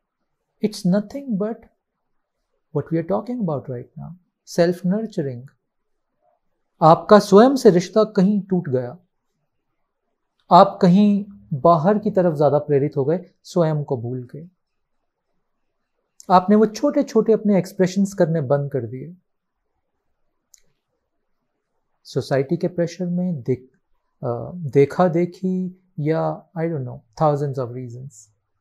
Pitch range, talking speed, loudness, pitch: 145-200 Hz, 115 wpm, -19 LUFS, 175 Hz